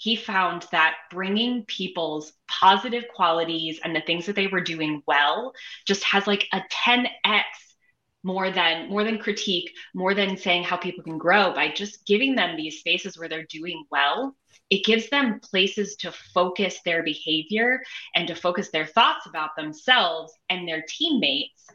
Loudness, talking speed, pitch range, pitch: -23 LUFS, 165 wpm, 165-210 Hz, 185 Hz